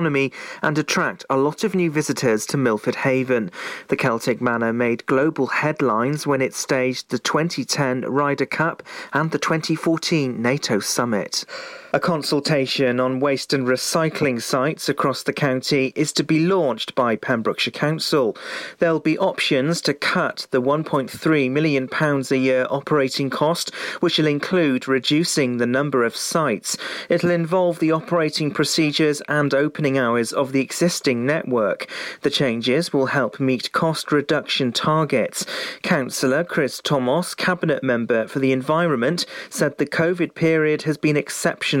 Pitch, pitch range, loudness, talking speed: 145 Hz, 130-160 Hz, -21 LUFS, 145 wpm